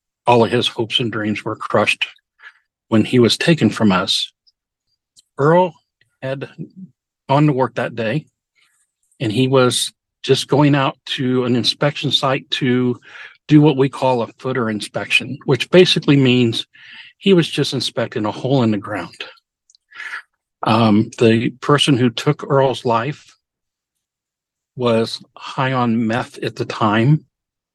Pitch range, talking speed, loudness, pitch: 115-140 Hz, 140 wpm, -17 LUFS, 125 Hz